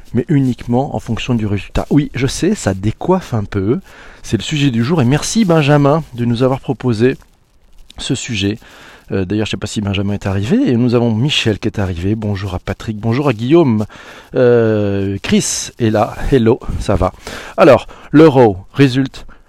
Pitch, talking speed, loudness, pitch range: 115 Hz, 185 wpm, -15 LUFS, 100-135 Hz